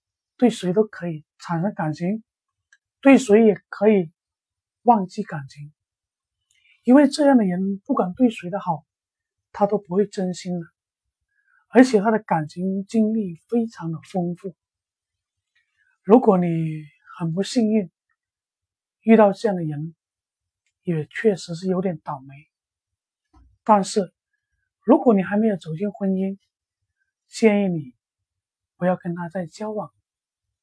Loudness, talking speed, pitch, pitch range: -21 LUFS, 180 characters per minute, 190 Hz, 155-215 Hz